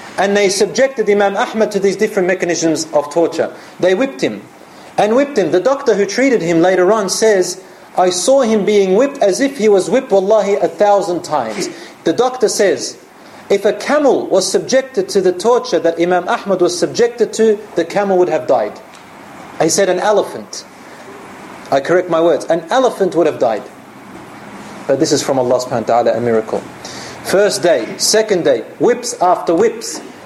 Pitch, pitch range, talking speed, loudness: 195 Hz, 175-220 Hz, 180 wpm, -14 LUFS